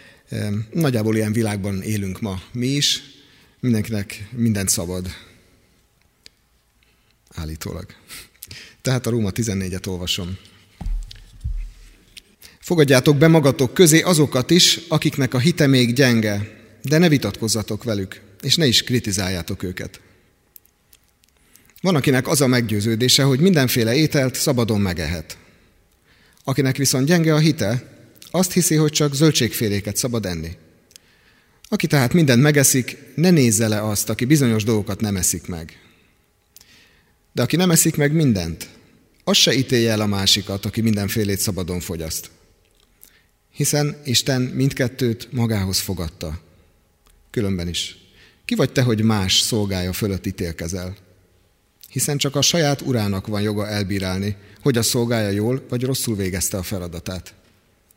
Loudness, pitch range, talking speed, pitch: -19 LUFS, 95-135 Hz, 125 wpm, 110 Hz